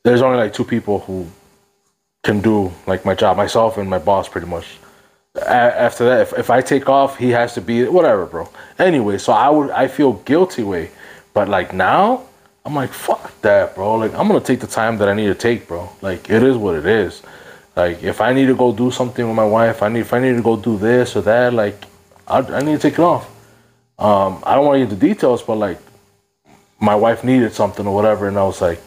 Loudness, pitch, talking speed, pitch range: -16 LUFS, 110 Hz, 235 wpm, 100-125 Hz